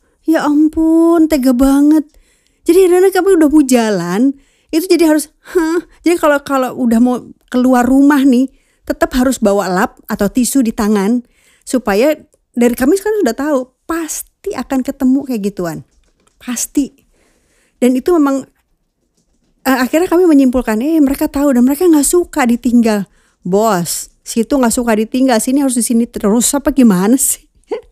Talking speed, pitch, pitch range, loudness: 150 wpm, 265 Hz, 240-310 Hz, -13 LUFS